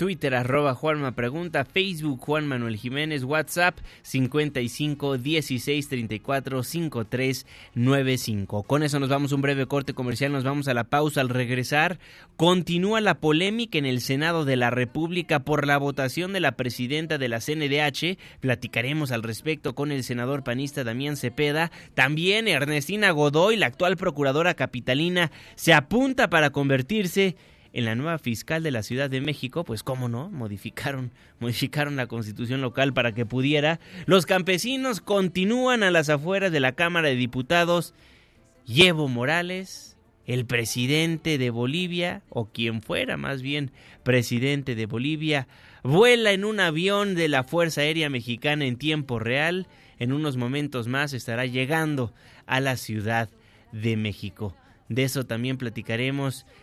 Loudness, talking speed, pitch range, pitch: -24 LUFS, 145 wpm, 125-160 Hz, 140 Hz